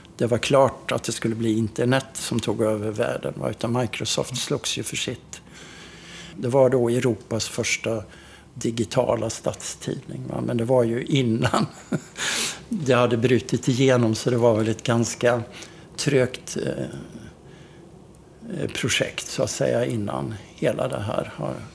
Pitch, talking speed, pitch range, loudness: 120 Hz, 135 wpm, 115-130 Hz, -24 LUFS